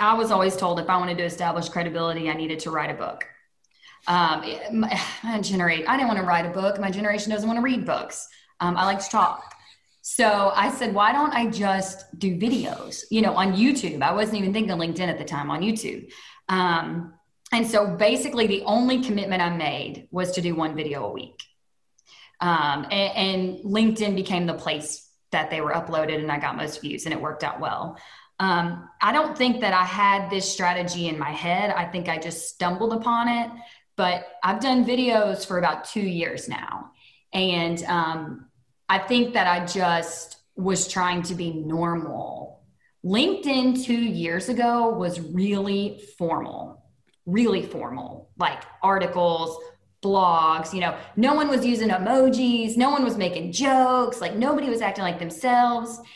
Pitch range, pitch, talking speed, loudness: 170-230 Hz, 190 Hz, 180 wpm, -24 LUFS